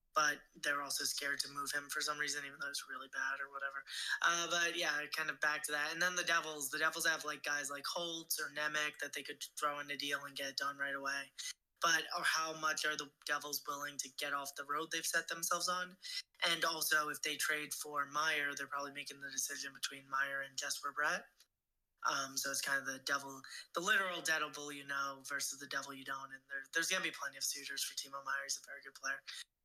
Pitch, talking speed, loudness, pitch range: 145 Hz, 240 wpm, -38 LUFS, 140-155 Hz